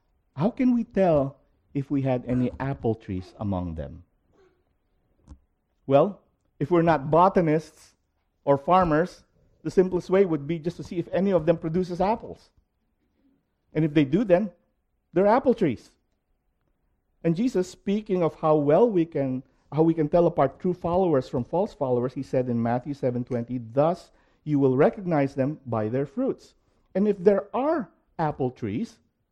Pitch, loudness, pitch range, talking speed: 155 Hz, -25 LUFS, 125-180 Hz, 160 wpm